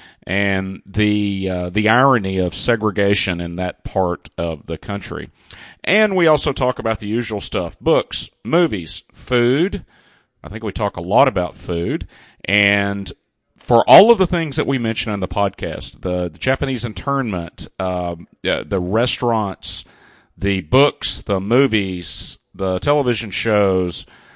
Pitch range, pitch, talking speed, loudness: 90-120 Hz, 100 Hz, 145 wpm, -18 LUFS